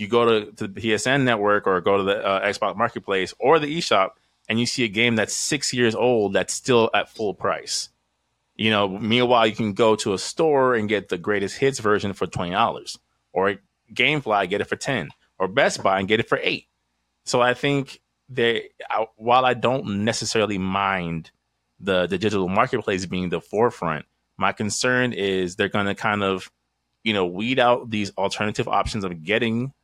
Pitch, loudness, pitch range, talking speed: 105 Hz, -22 LUFS, 95-120 Hz, 195 wpm